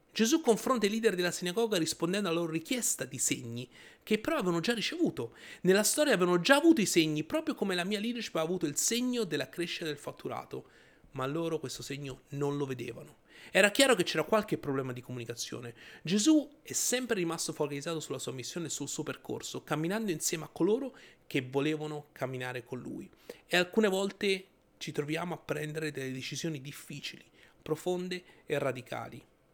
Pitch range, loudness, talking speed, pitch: 145-210 Hz, -32 LUFS, 175 wpm, 165 Hz